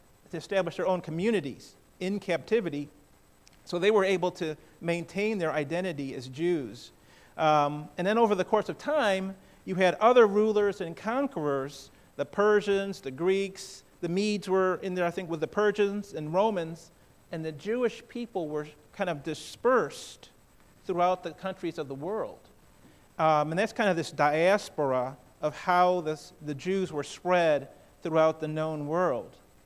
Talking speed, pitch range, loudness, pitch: 160 wpm, 155-200 Hz, -28 LUFS, 180 Hz